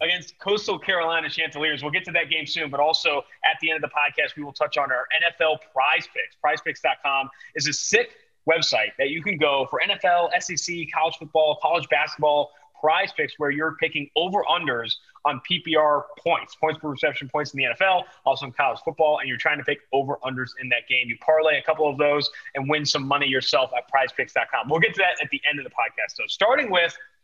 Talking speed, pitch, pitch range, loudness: 220 wpm, 155 Hz, 145-165 Hz, -23 LUFS